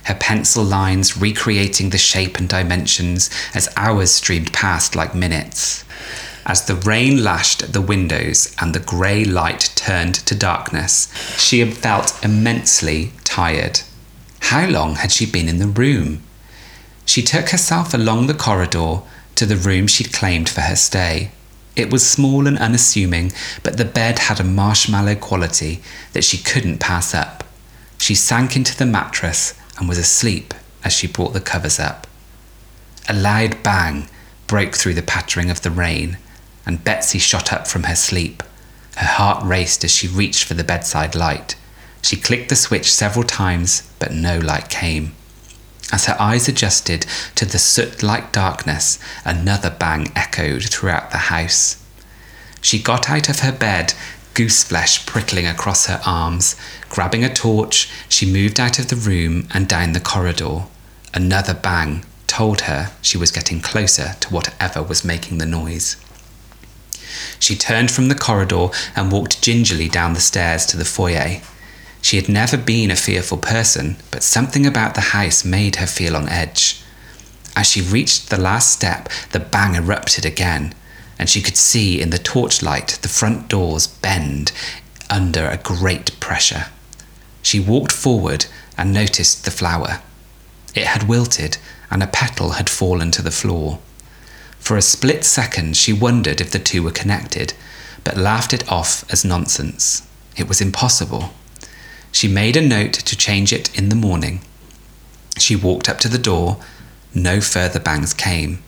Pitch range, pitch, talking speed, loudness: 85-110 Hz, 95 Hz, 160 wpm, -16 LUFS